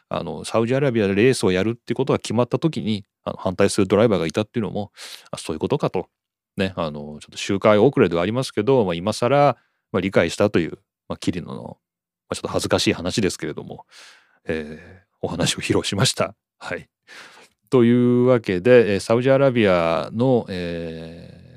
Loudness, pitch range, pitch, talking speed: -20 LUFS, 90-125 Hz, 110 Hz, 405 characters per minute